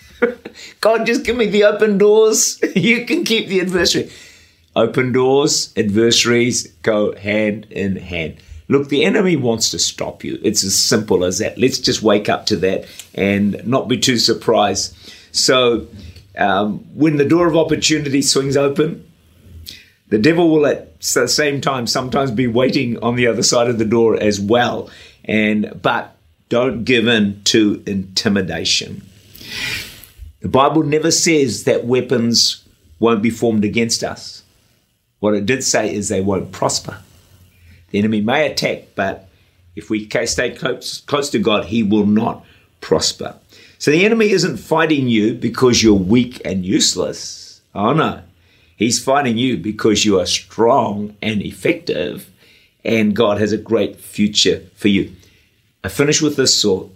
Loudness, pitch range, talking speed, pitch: -16 LUFS, 100-140 Hz, 155 wpm, 115 Hz